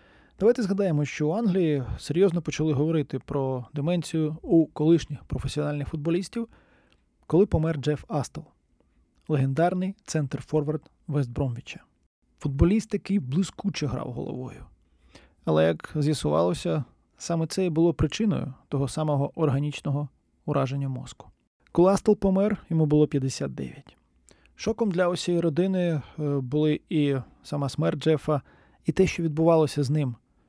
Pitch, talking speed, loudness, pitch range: 155 Hz, 120 wpm, -26 LUFS, 140-175 Hz